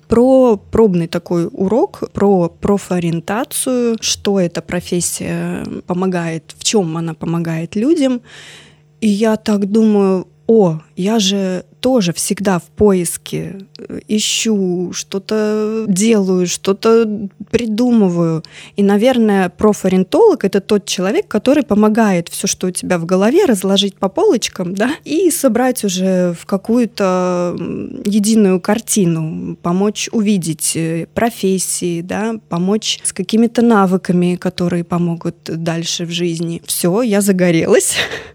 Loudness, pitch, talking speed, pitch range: -15 LUFS, 195 Hz, 115 wpm, 175-215 Hz